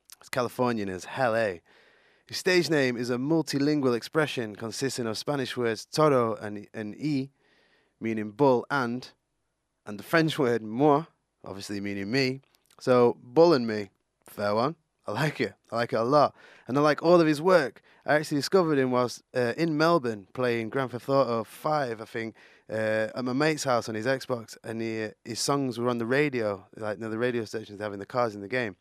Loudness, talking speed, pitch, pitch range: -27 LUFS, 195 wpm, 125 Hz, 110-145 Hz